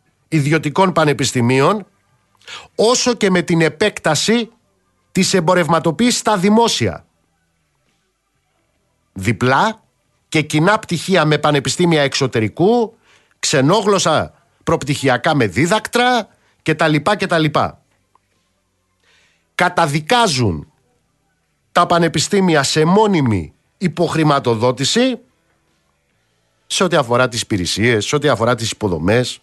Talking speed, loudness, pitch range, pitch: 85 wpm, -15 LUFS, 120-185 Hz, 155 Hz